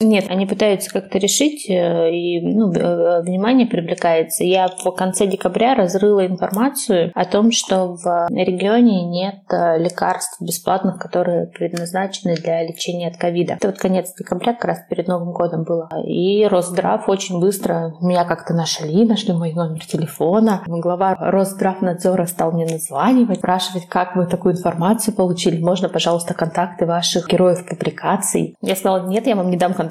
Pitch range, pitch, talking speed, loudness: 175-195 Hz, 180 Hz, 150 wpm, -18 LUFS